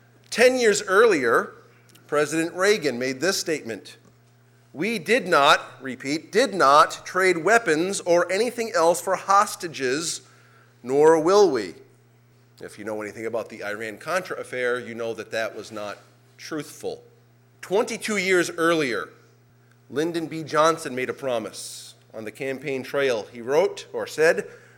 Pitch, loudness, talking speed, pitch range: 150 Hz, -22 LUFS, 140 wpm, 120-190 Hz